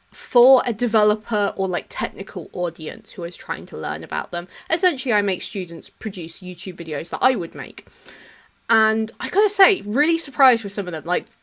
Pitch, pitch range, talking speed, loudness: 210 Hz, 180-250 Hz, 190 wpm, -21 LUFS